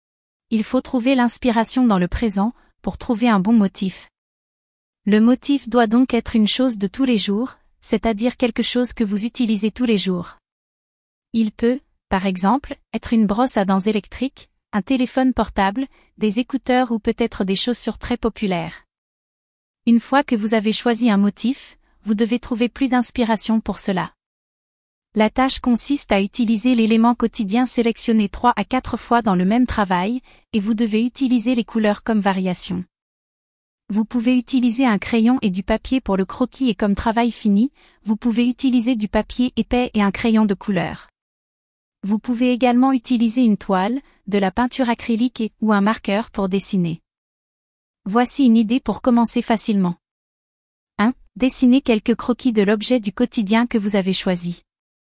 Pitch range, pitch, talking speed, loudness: 205-245 Hz, 230 Hz, 165 wpm, -19 LUFS